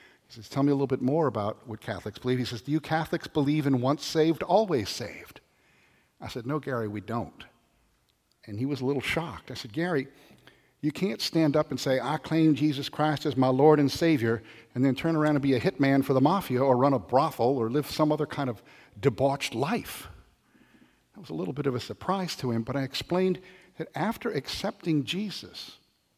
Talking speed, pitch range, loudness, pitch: 215 wpm, 130-155 Hz, -27 LUFS, 140 Hz